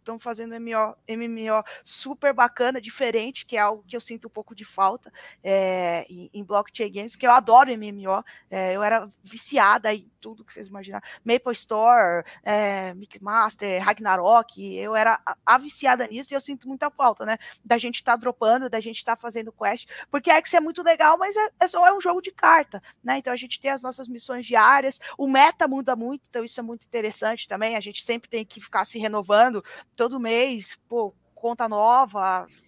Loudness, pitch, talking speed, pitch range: -22 LUFS, 230 Hz, 200 wpm, 210-255 Hz